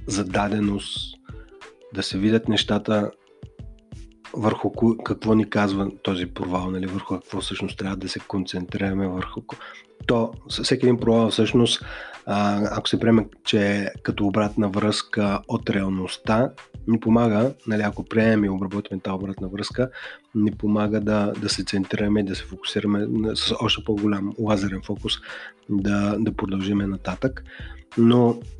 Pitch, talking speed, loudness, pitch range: 105 Hz, 140 wpm, -23 LUFS, 100-110 Hz